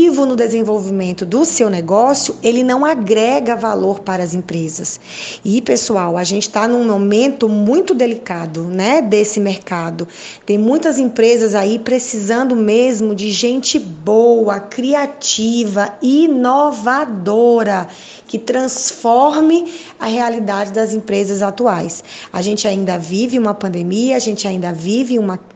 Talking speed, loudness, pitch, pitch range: 125 wpm, -14 LUFS, 220 Hz, 200-250 Hz